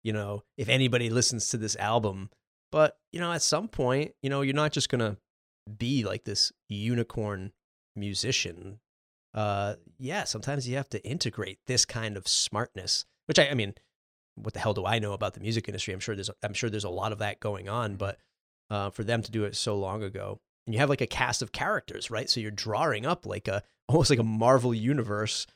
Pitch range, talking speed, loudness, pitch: 100-125 Hz, 220 wpm, -29 LUFS, 110 Hz